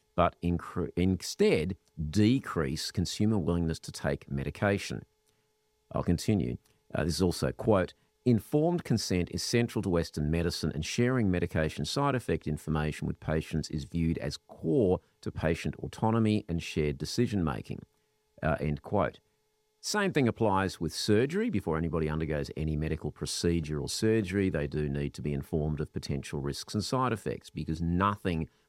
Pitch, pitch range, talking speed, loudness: 85 Hz, 75-105 Hz, 150 wpm, -31 LUFS